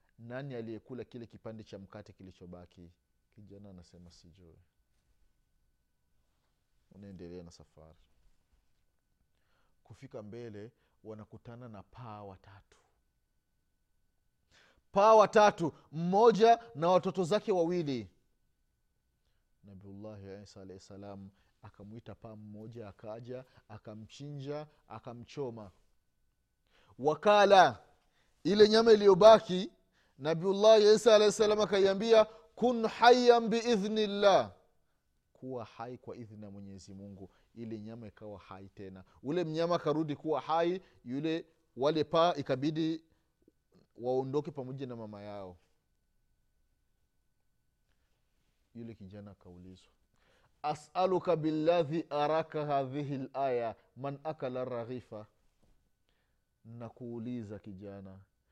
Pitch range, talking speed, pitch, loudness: 100-160 Hz, 85 wpm, 115 Hz, -28 LUFS